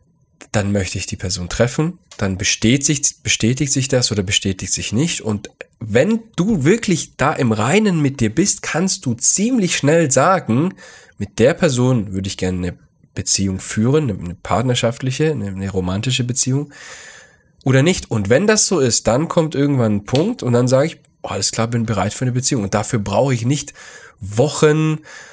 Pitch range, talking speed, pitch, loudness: 105-155 Hz, 175 wpm, 125 Hz, -17 LUFS